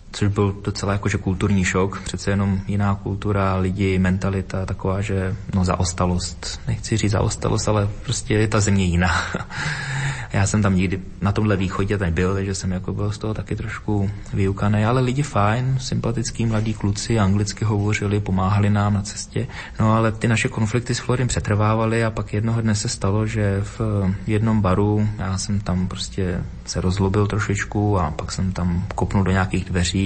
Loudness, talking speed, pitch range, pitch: -22 LUFS, 175 wpm, 95-110 Hz, 100 Hz